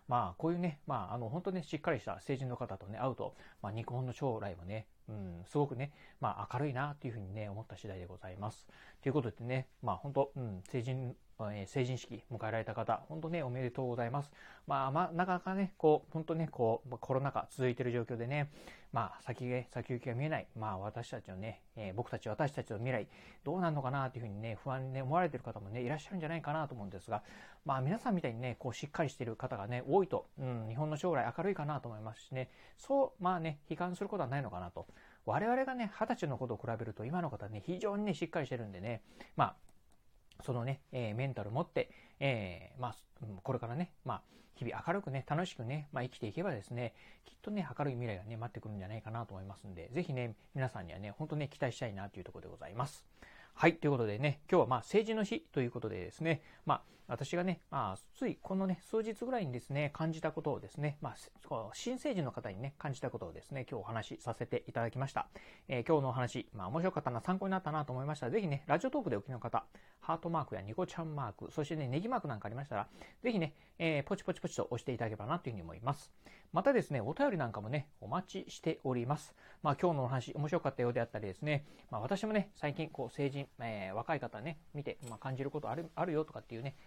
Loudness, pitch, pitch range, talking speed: -39 LUFS, 135 Hz, 115-160 Hz, 470 characters per minute